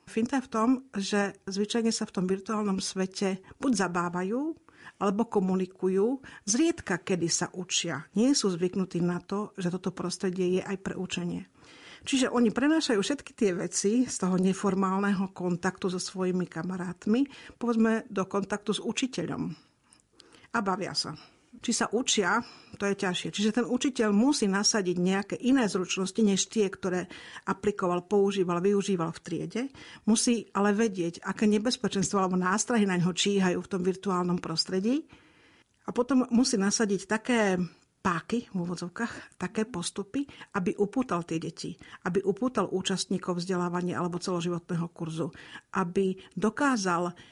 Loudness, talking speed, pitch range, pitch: -29 LUFS, 140 wpm, 180-225 Hz, 195 Hz